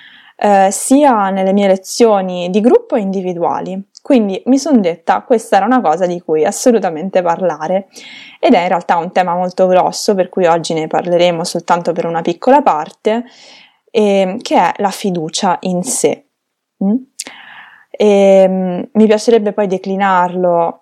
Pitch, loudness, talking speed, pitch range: 195 Hz, -13 LUFS, 155 wpm, 180-240 Hz